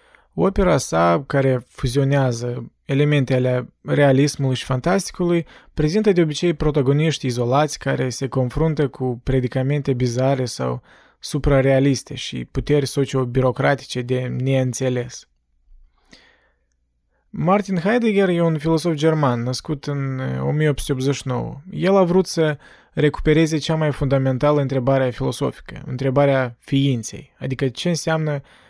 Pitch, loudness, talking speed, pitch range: 135 Hz, -20 LUFS, 105 wpm, 130-155 Hz